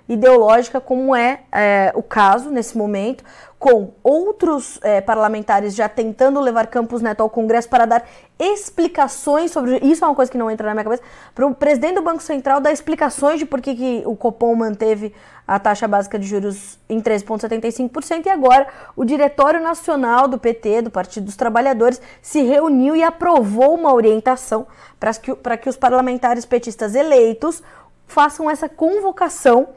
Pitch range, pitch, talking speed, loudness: 225-290 Hz, 255 Hz, 165 wpm, -17 LUFS